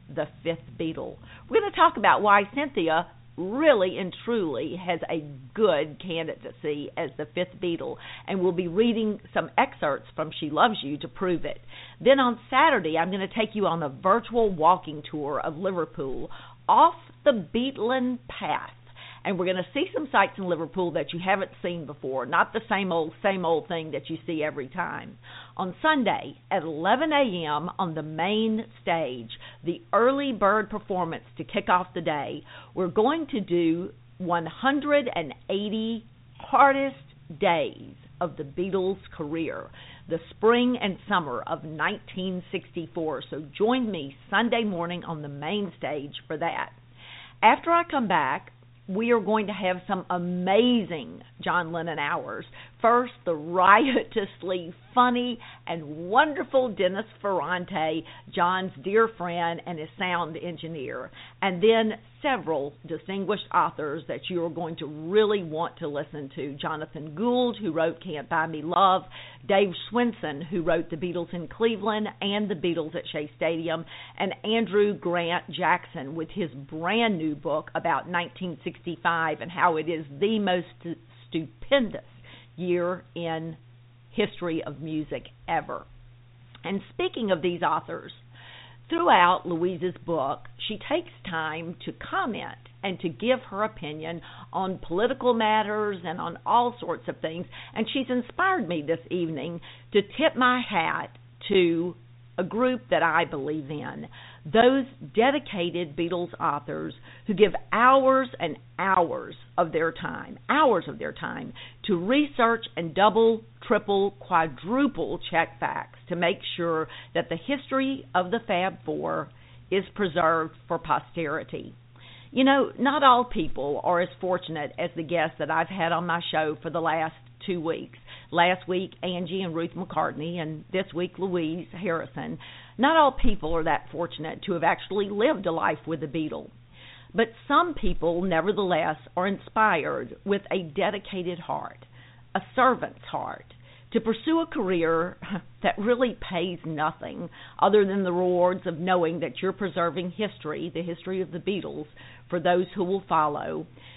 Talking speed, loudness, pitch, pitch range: 150 wpm, -26 LUFS, 175 Hz, 160-205 Hz